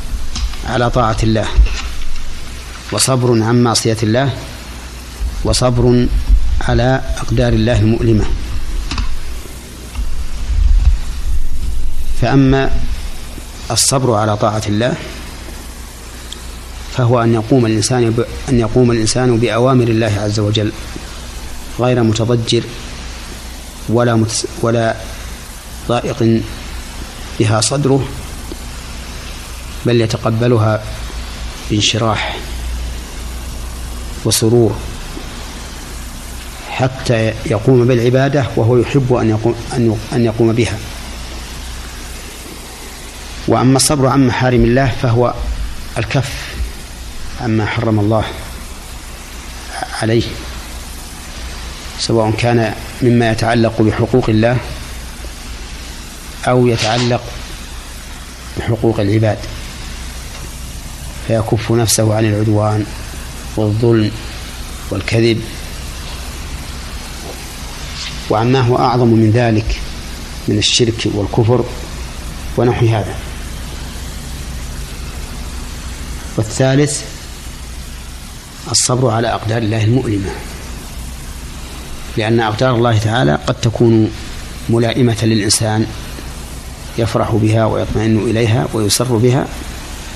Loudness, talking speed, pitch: -15 LUFS, 70 wpm, 90 Hz